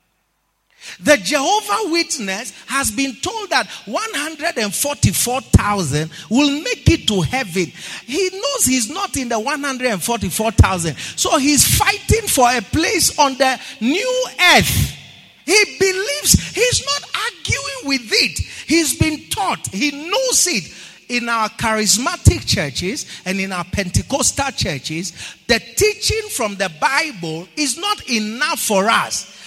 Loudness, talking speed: -17 LUFS, 125 wpm